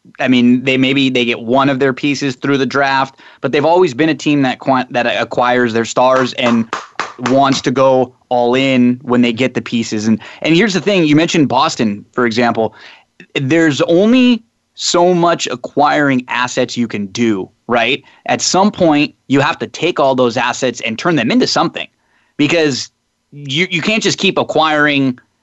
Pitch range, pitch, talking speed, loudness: 125-155 Hz, 135 Hz, 185 wpm, -13 LUFS